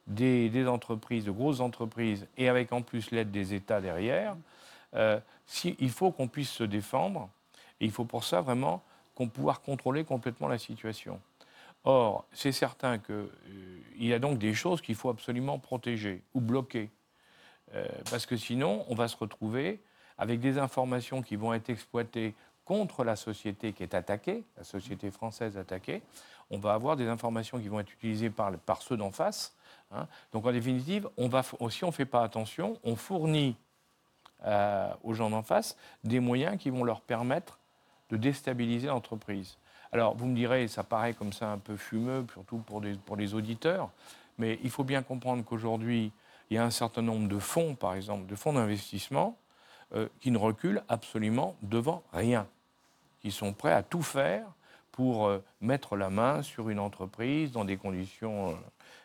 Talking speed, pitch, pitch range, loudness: 180 wpm, 115 Hz, 105-130 Hz, -33 LUFS